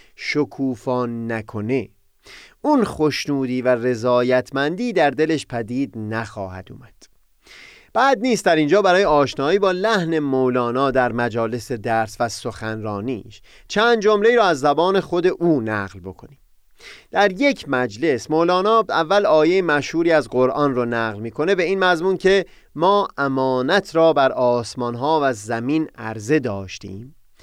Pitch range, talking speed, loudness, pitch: 120-170 Hz, 130 wpm, -19 LUFS, 135 Hz